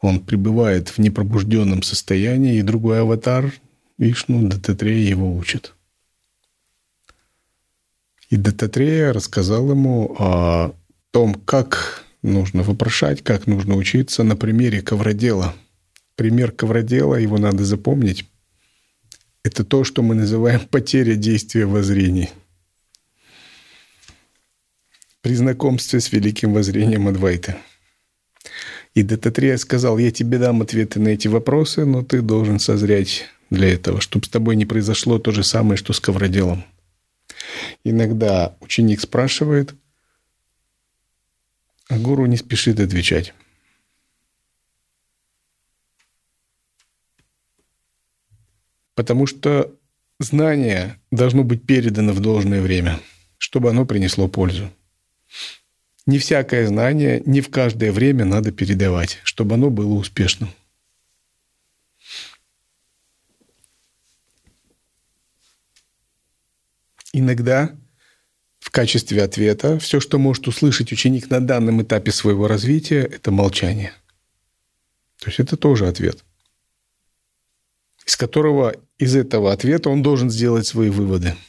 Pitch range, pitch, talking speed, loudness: 100-125 Hz, 110 Hz, 100 wpm, -18 LUFS